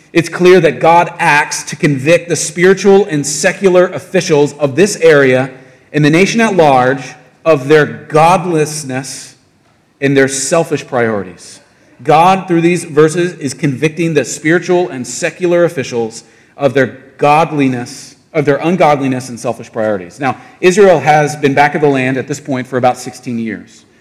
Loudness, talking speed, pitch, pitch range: -11 LUFS, 155 wpm, 145 Hz, 130-170 Hz